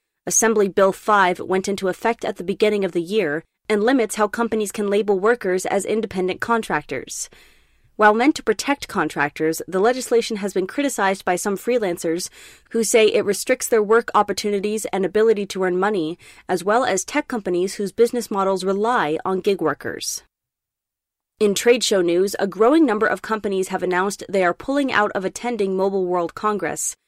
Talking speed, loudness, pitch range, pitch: 175 wpm, -20 LUFS, 185-225 Hz, 205 Hz